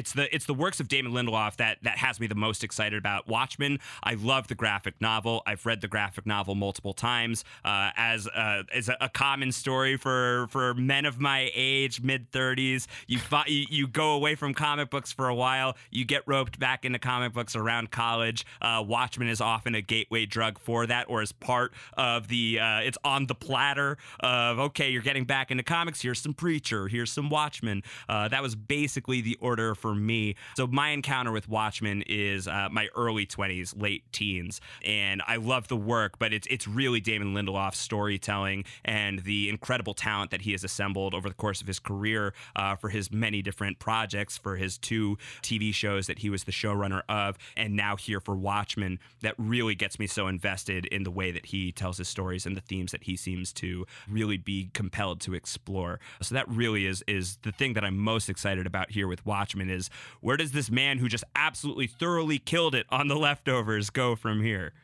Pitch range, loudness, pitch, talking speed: 100-130 Hz, -29 LUFS, 110 Hz, 205 wpm